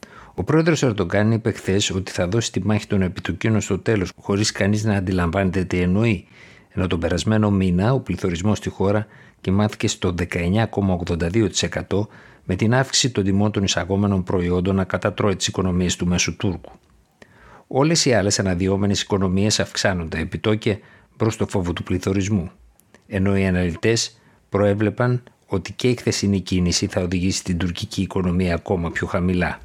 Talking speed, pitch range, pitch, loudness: 150 wpm, 90-105 Hz, 100 Hz, -21 LUFS